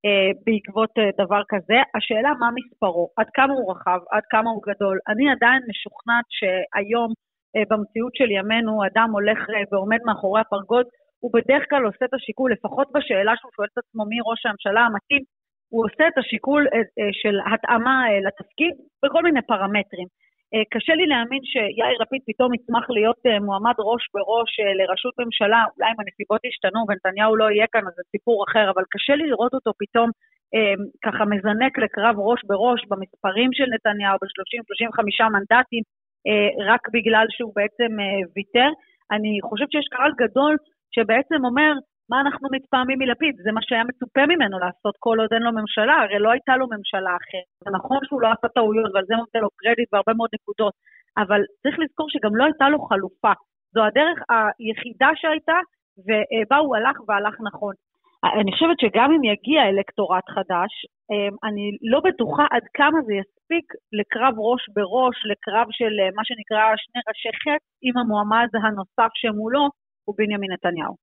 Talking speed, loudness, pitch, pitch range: 160 wpm, -21 LUFS, 225 Hz, 205-255 Hz